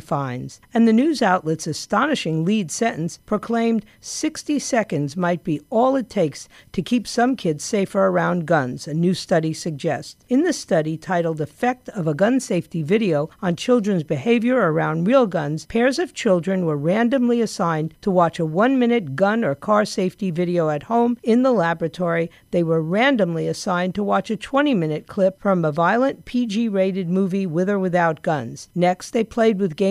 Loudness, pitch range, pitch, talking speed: -21 LUFS, 165-230 Hz, 190 Hz, 180 wpm